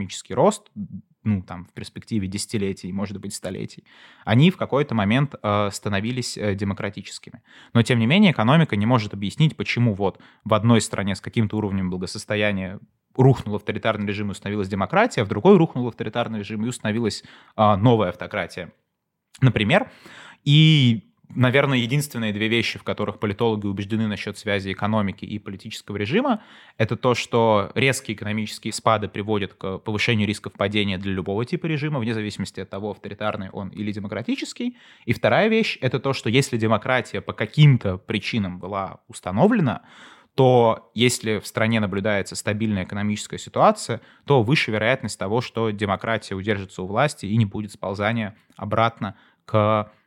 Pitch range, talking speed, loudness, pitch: 100-120 Hz, 150 wpm, -22 LUFS, 110 Hz